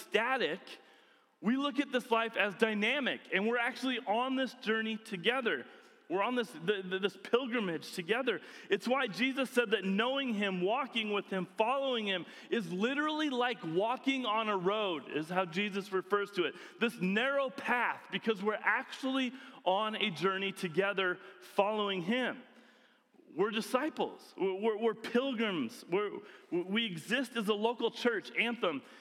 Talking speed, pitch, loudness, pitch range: 155 wpm, 230 Hz, -33 LUFS, 200-260 Hz